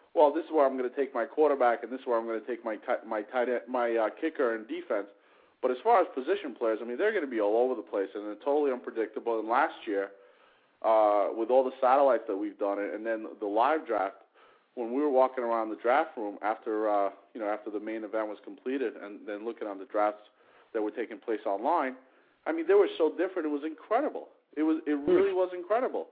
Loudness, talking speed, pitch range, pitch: -30 LUFS, 250 wpm, 110-160 Hz, 125 Hz